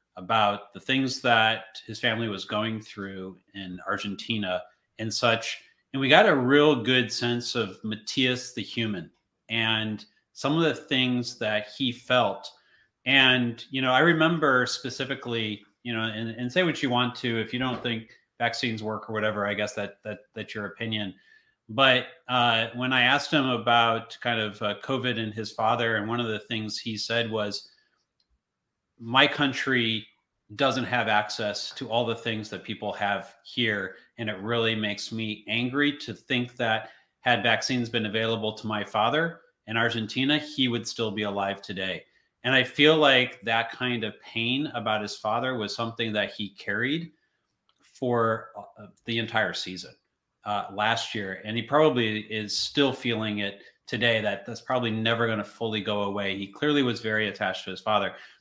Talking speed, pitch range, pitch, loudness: 175 wpm, 105-125 Hz, 115 Hz, -26 LUFS